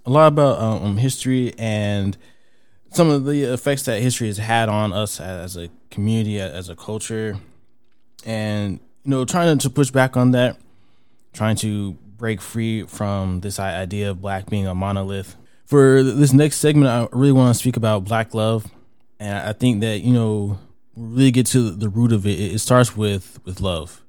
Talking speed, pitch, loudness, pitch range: 185 wpm, 110 Hz, -19 LUFS, 100-125 Hz